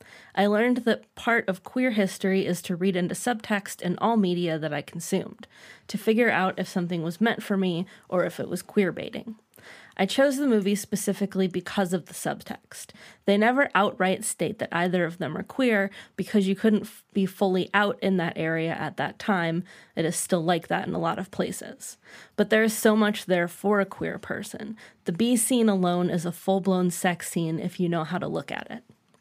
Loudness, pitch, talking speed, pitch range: -26 LUFS, 195 Hz, 210 wpm, 180-215 Hz